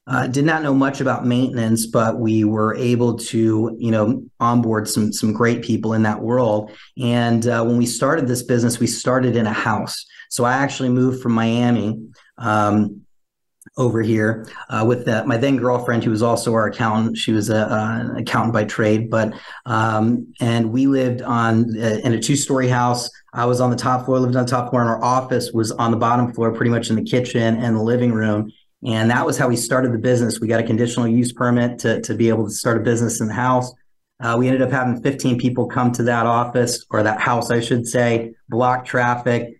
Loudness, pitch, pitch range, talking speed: -19 LUFS, 120 Hz, 115-125 Hz, 220 wpm